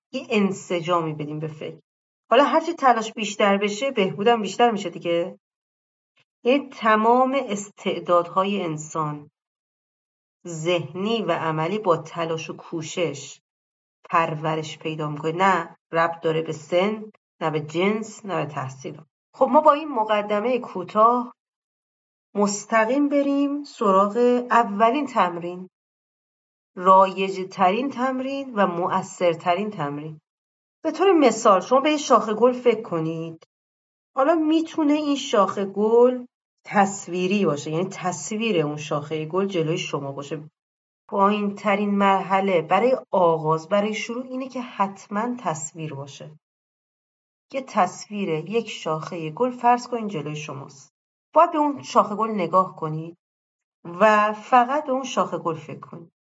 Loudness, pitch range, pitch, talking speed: -22 LUFS, 165-235 Hz, 195 Hz, 125 wpm